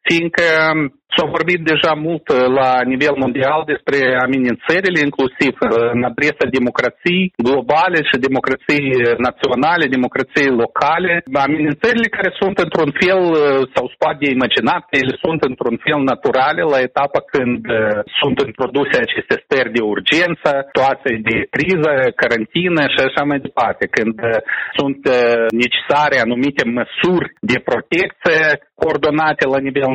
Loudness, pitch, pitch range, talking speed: -15 LUFS, 140 Hz, 125-165 Hz, 120 wpm